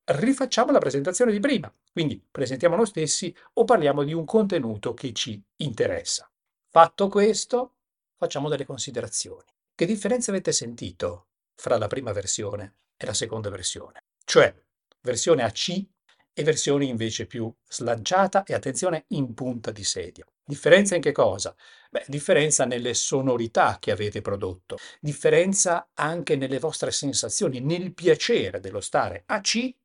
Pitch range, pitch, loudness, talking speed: 130-215 Hz, 165 Hz, -24 LUFS, 140 wpm